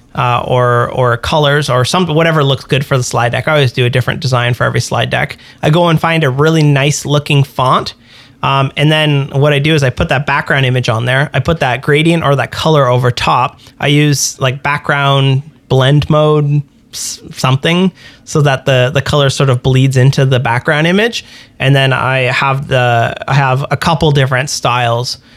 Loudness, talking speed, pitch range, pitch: -11 LUFS, 205 wpm, 125-150 Hz, 135 Hz